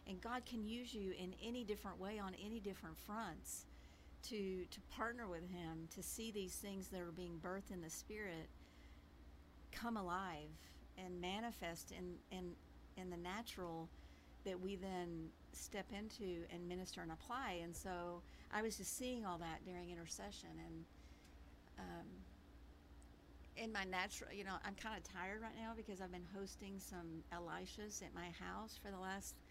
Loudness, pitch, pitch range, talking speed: -50 LUFS, 180 Hz, 160-200 Hz, 165 wpm